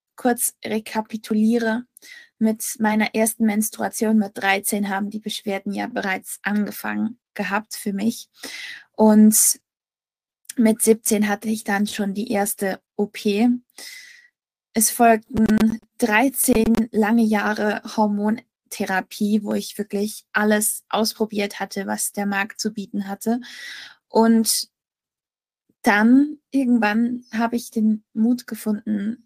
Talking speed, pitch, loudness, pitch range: 110 wpm, 220 Hz, -21 LUFS, 205-230 Hz